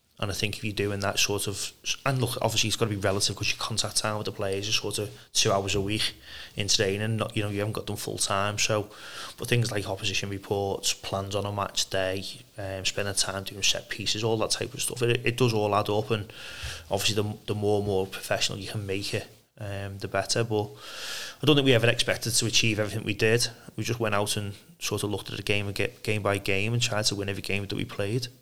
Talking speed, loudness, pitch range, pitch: 260 wpm, -27 LUFS, 100-110 Hz, 105 Hz